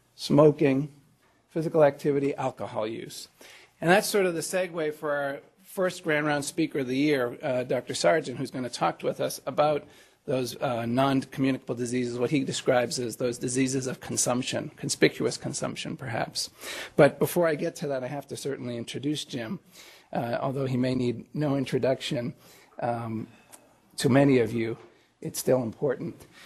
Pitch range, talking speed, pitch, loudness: 125-150 Hz, 165 wpm, 140 Hz, -27 LUFS